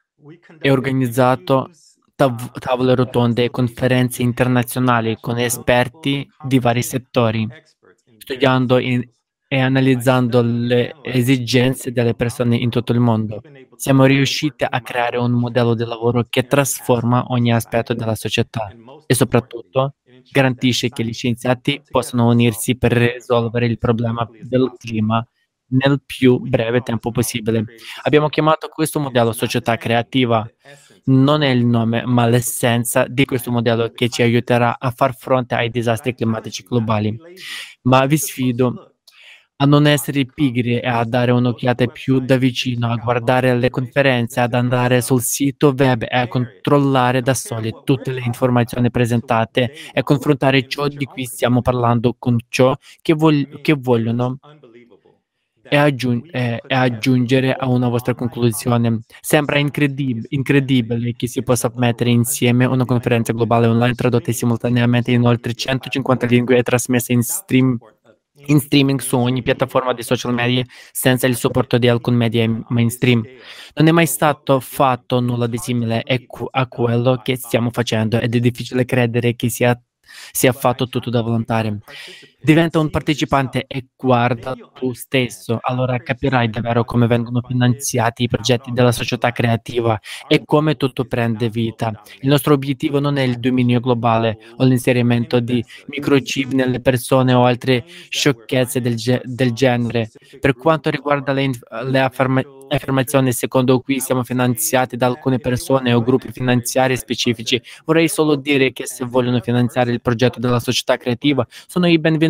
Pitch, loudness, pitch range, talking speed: 125 Hz, -17 LUFS, 120-135 Hz, 145 wpm